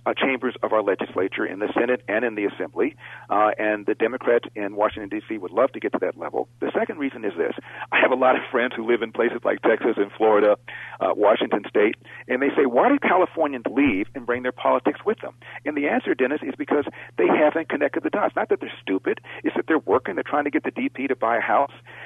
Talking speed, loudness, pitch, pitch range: 250 wpm, -23 LUFS, 120 Hz, 105-135 Hz